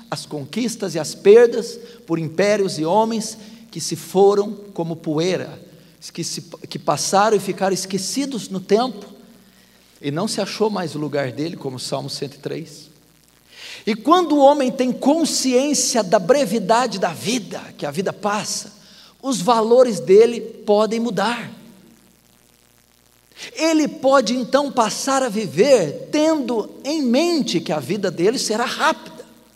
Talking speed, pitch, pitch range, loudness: 140 wpm, 215 Hz, 170-245 Hz, -19 LUFS